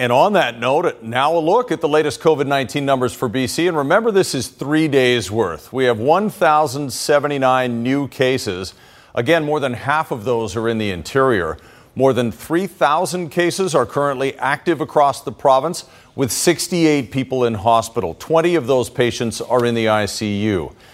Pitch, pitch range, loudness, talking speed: 135 Hz, 120-155 Hz, -18 LUFS, 170 wpm